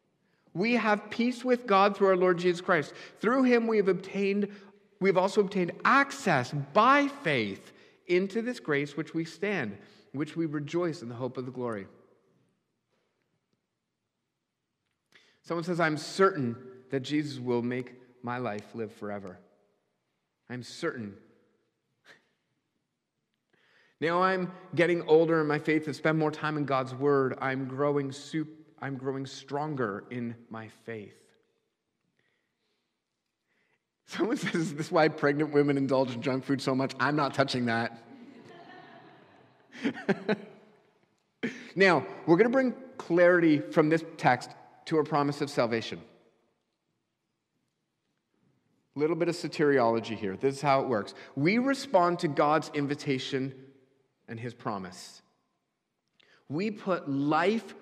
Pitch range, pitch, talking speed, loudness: 135-190 Hz, 155 Hz, 130 wpm, -28 LUFS